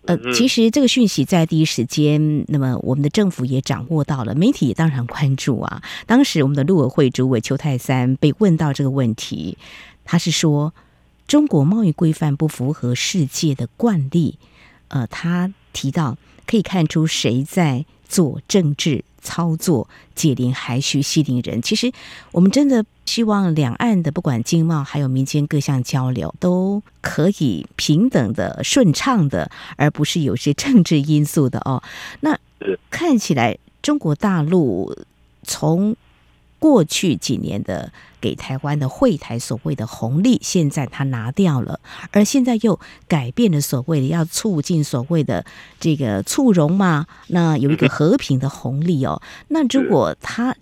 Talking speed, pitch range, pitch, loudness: 235 characters per minute, 135-180 Hz, 155 Hz, -18 LUFS